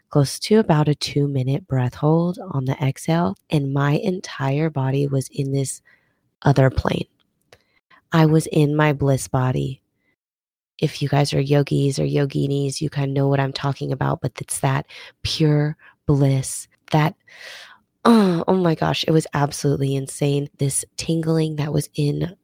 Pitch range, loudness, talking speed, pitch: 135-155 Hz, -21 LUFS, 160 wpm, 145 Hz